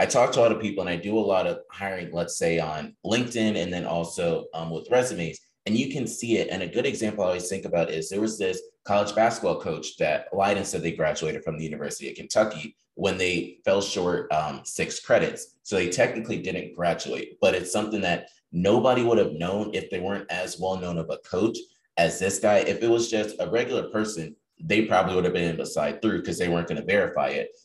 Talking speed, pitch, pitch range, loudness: 230 wpm, 95 Hz, 85-110 Hz, -26 LUFS